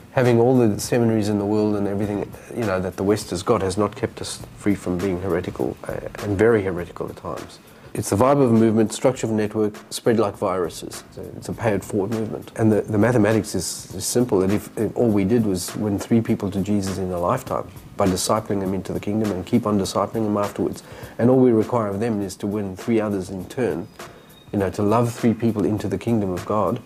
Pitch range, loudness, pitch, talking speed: 100-115 Hz, -22 LUFS, 105 Hz, 245 wpm